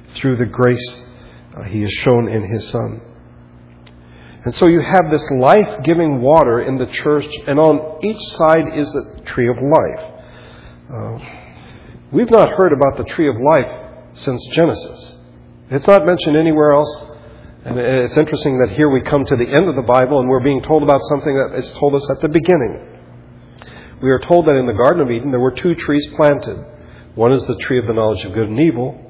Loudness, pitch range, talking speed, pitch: -14 LUFS, 115-150 Hz, 200 wpm, 135 Hz